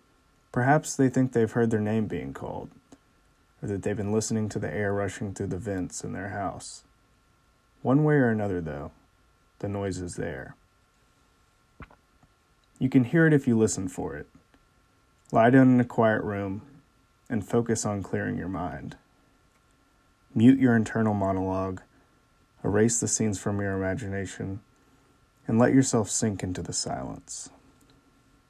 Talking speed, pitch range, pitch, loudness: 150 wpm, 100-130 Hz, 110 Hz, -26 LUFS